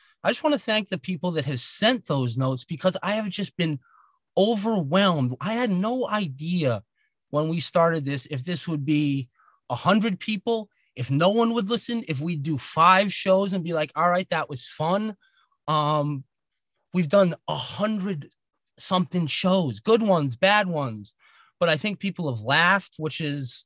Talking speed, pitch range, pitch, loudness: 180 wpm, 150-200 Hz, 175 Hz, -24 LUFS